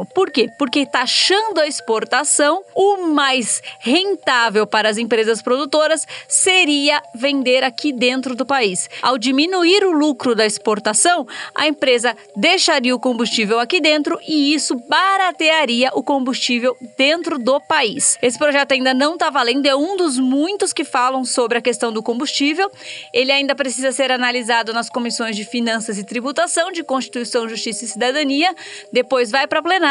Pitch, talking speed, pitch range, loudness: 270 Hz, 155 wpm, 245-310 Hz, -16 LUFS